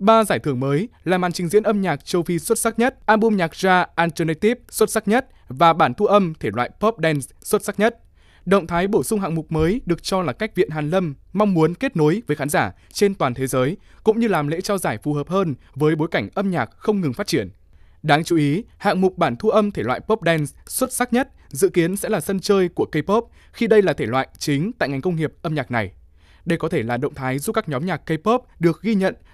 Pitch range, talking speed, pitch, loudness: 150-210 Hz, 260 wpm, 175 Hz, -20 LUFS